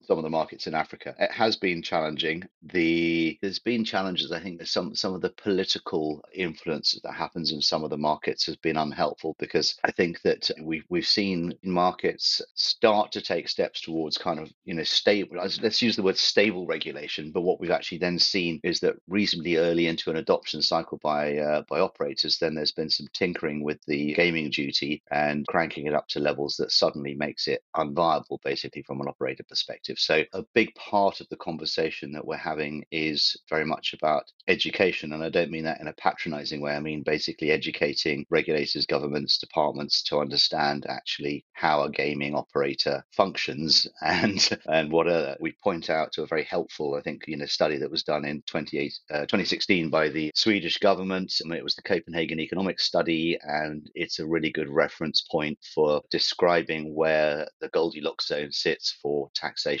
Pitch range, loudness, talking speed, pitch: 75-85 Hz, -26 LUFS, 190 wpm, 80 Hz